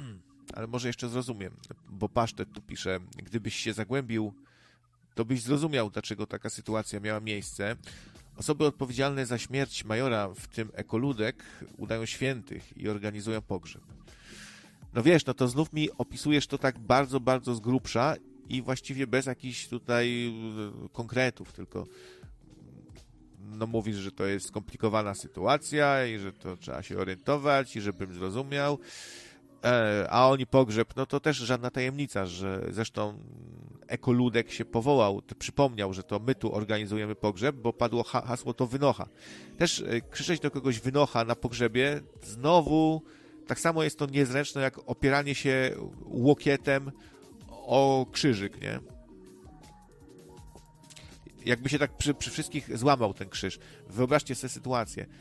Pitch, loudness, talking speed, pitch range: 120 Hz, -30 LUFS, 135 wpm, 105-135 Hz